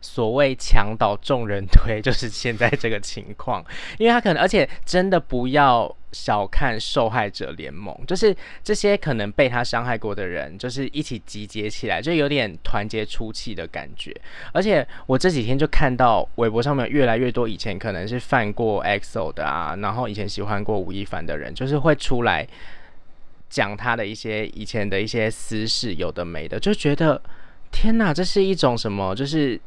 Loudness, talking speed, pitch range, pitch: -22 LUFS, 280 characters per minute, 105-145 Hz, 120 Hz